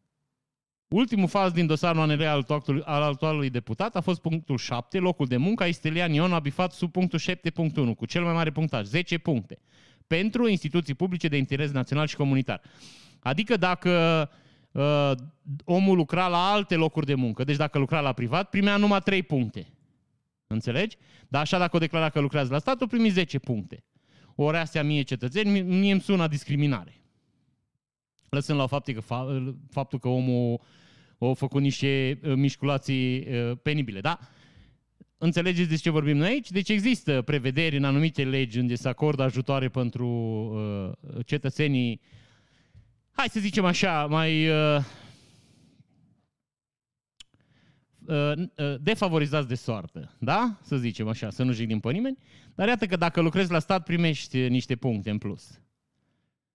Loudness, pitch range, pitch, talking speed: -26 LUFS, 130-170 Hz, 145 Hz, 150 wpm